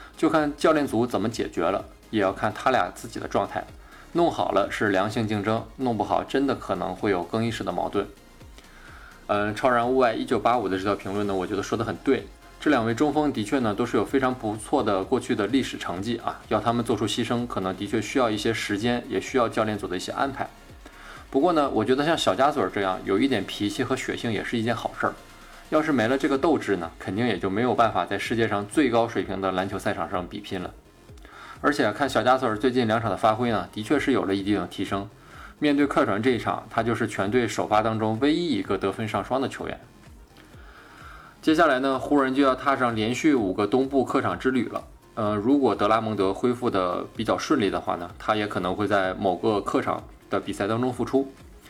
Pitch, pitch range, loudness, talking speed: 110 Hz, 105-125 Hz, -25 LUFS, 335 characters per minute